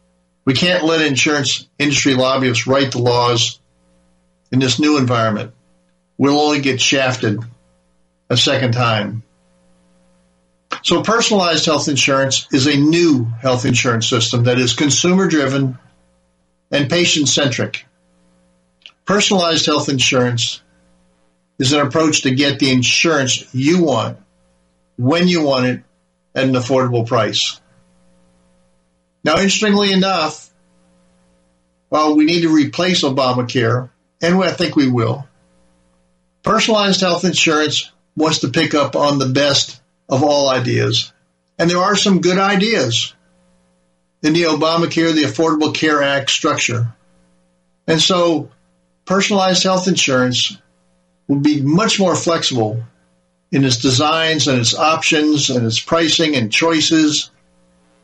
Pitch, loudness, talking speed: 130 Hz, -15 LUFS, 125 wpm